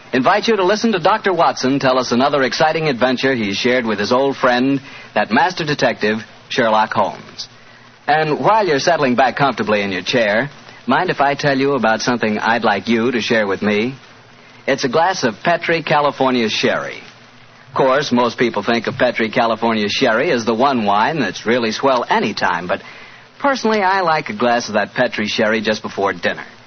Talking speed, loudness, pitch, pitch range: 185 wpm, -16 LUFS, 125 Hz, 110-140 Hz